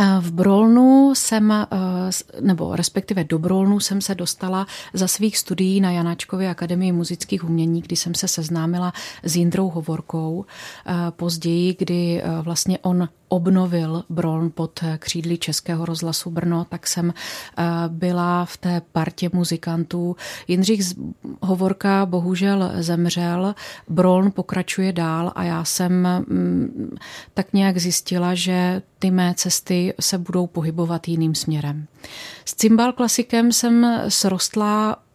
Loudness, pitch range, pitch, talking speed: -20 LUFS, 170-190 Hz, 180 Hz, 120 wpm